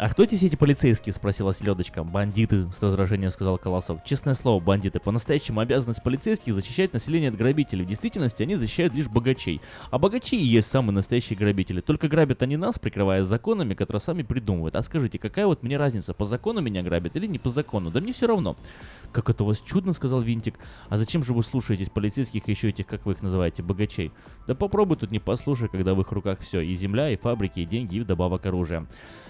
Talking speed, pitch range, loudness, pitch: 205 wpm, 95-135 Hz, -25 LUFS, 110 Hz